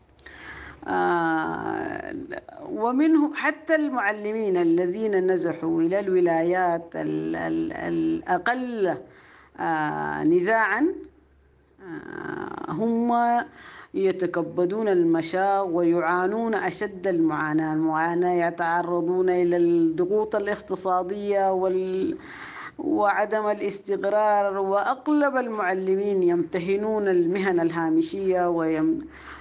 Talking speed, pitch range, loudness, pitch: 65 wpm, 170-235 Hz, -24 LUFS, 190 Hz